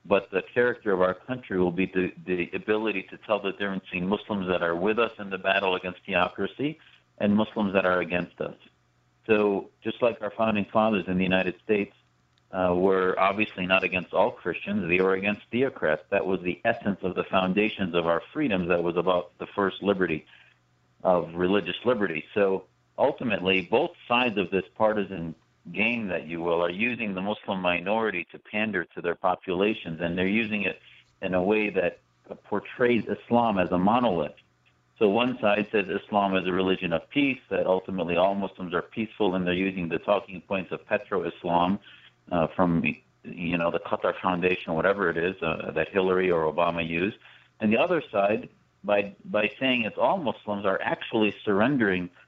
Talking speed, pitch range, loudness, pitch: 185 wpm, 90-105 Hz, -26 LUFS, 95 Hz